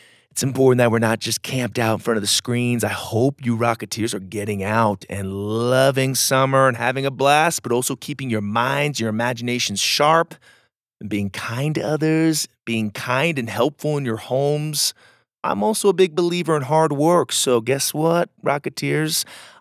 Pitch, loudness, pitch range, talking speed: 130 Hz, -20 LUFS, 115-150 Hz, 180 wpm